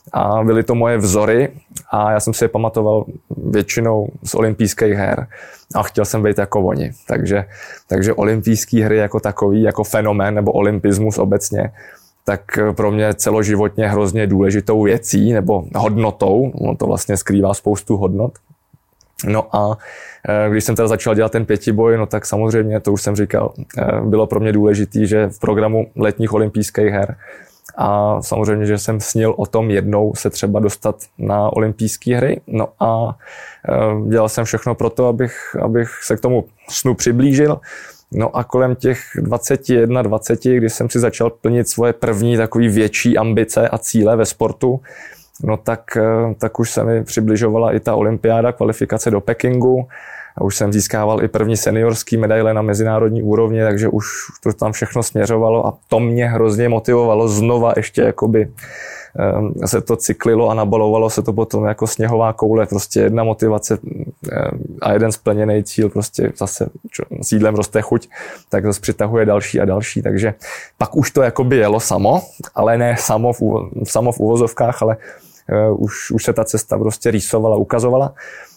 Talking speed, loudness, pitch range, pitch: 160 wpm, -16 LUFS, 105-115 Hz, 110 Hz